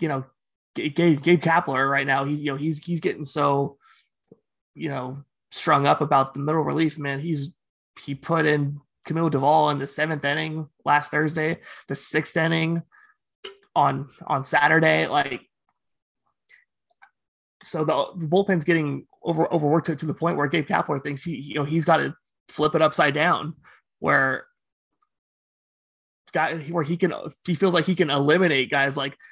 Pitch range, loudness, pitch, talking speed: 145-170 Hz, -23 LUFS, 155 Hz, 165 wpm